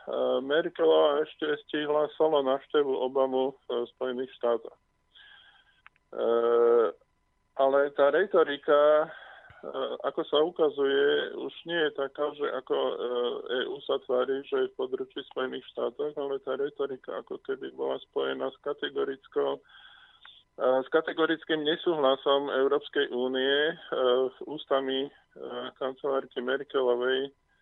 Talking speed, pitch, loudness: 100 wpm, 160 Hz, -28 LUFS